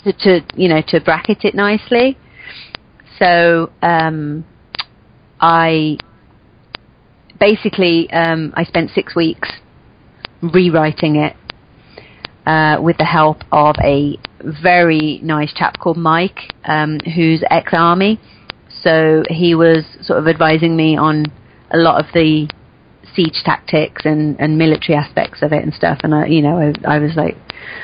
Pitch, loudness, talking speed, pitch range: 160 Hz, -13 LUFS, 135 wpm, 155-170 Hz